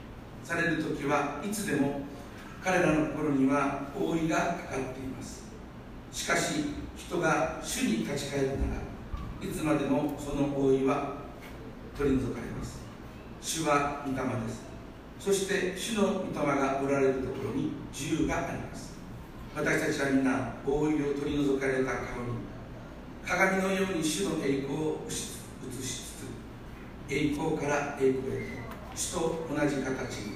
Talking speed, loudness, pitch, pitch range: 255 characters per minute, -31 LUFS, 140 Hz, 135-155 Hz